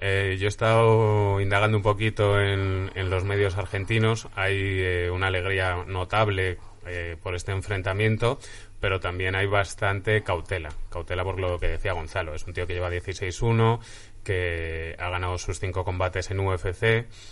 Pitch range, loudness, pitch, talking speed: 90-105 Hz, -26 LUFS, 95 Hz, 160 wpm